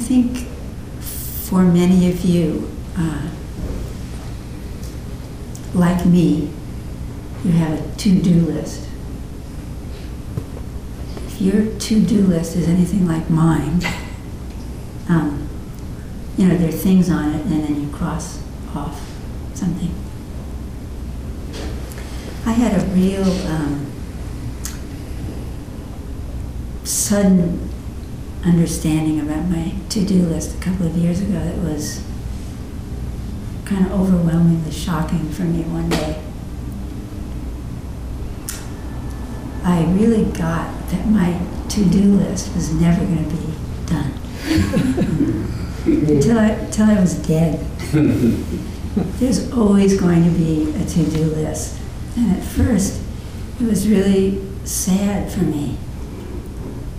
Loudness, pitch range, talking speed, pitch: -19 LUFS, 150-190 Hz, 110 wpm, 170 Hz